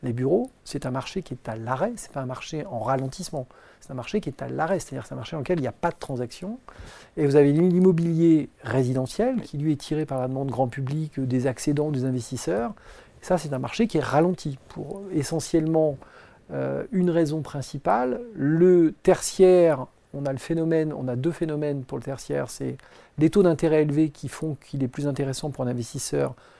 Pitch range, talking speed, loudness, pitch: 130-165 Hz, 210 wpm, -25 LUFS, 150 Hz